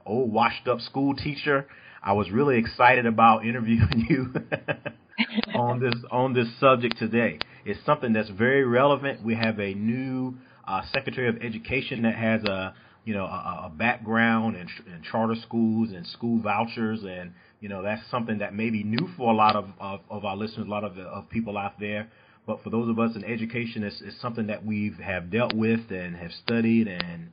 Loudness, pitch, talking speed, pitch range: -26 LUFS, 115 Hz, 200 wpm, 105-125 Hz